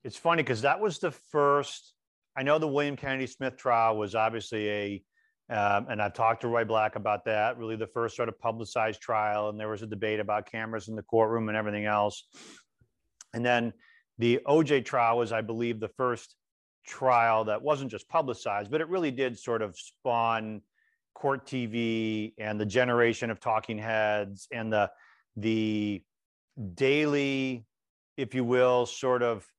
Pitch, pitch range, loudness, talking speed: 115 Hz, 110-130 Hz, -29 LUFS, 170 wpm